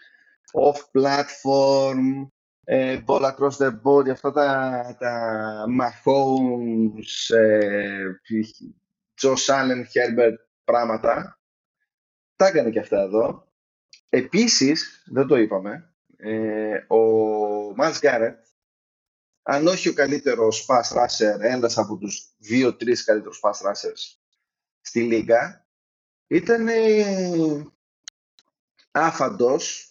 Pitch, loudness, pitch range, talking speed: 130 Hz, -21 LUFS, 110-145 Hz, 90 wpm